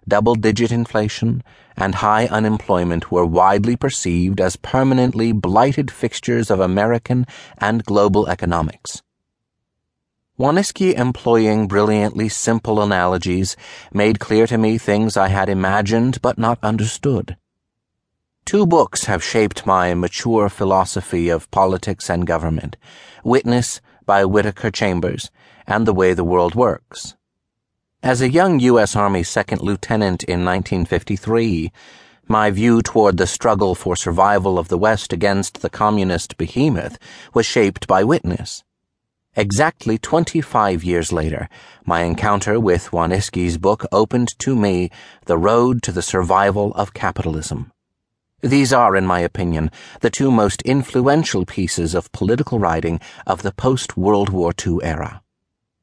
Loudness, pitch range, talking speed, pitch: -17 LUFS, 90-115 Hz, 130 wpm, 105 Hz